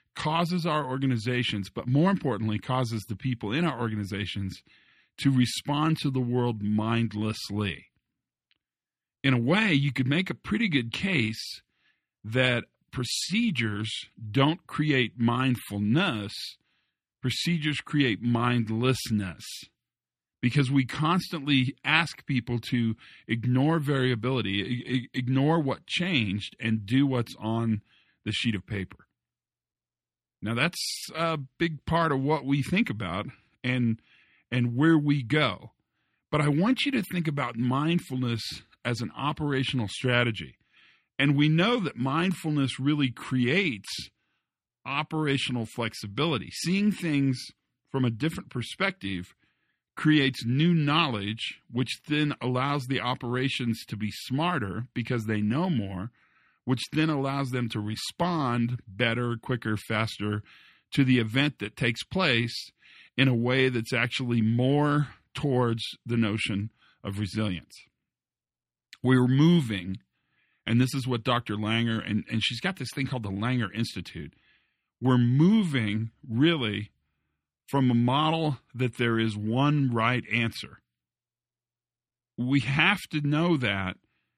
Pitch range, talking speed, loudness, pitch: 110-145 Hz, 125 wpm, -27 LUFS, 125 Hz